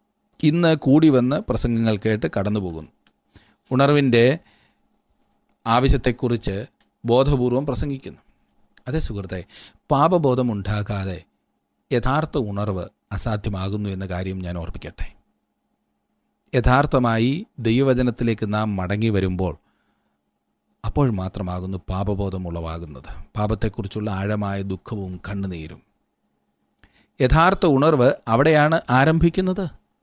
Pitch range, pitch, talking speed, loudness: 95-135 Hz, 110 Hz, 80 wpm, -21 LUFS